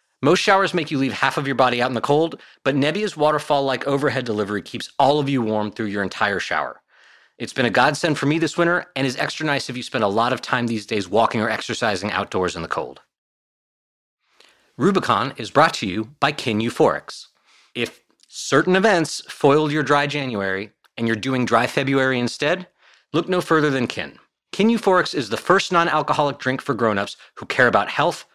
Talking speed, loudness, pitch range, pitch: 200 wpm, -20 LUFS, 120-155 Hz, 140 Hz